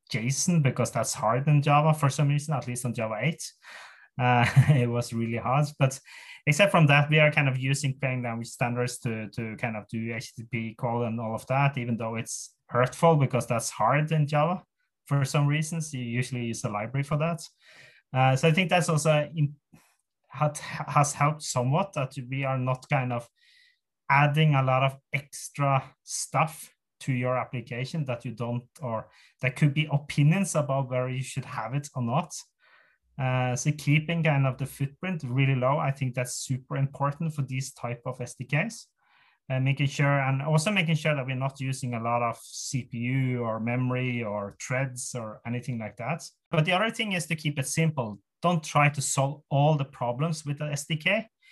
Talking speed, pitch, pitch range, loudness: 190 wpm, 135 Hz, 125-150 Hz, -27 LUFS